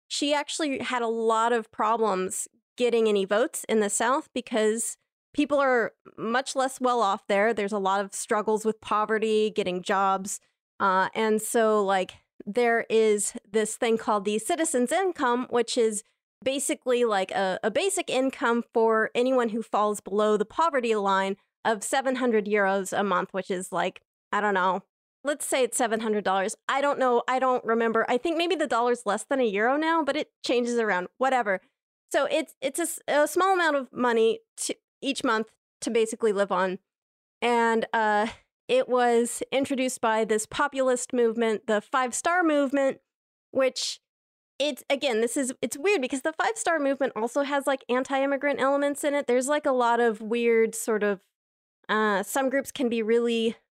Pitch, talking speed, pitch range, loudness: 235 Hz, 175 wpm, 215-270 Hz, -26 LUFS